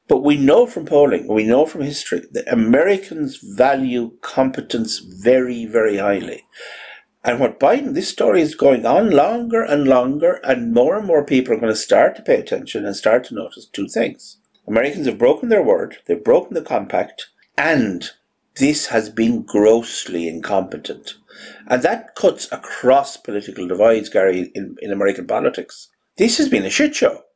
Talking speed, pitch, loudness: 170 wpm, 130 Hz, -17 LUFS